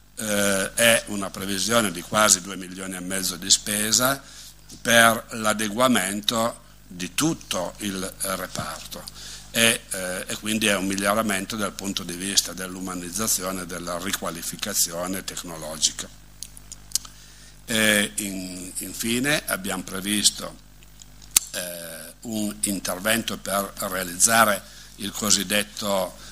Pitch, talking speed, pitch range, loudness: 100 Hz, 105 wpm, 95-110 Hz, -23 LUFS